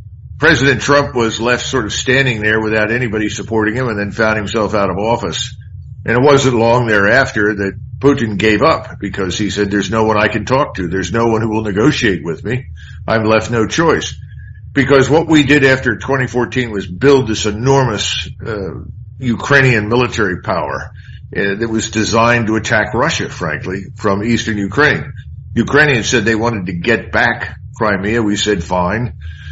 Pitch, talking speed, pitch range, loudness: 110 Hz, 175 wpm, 105-125 Hz, -14 LUFS